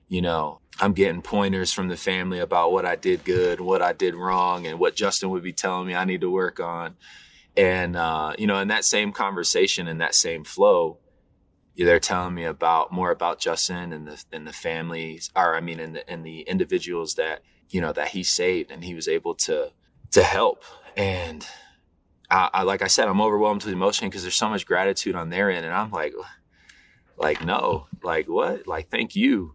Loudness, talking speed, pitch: -23 LUFS, 205 wpm, 95 Hz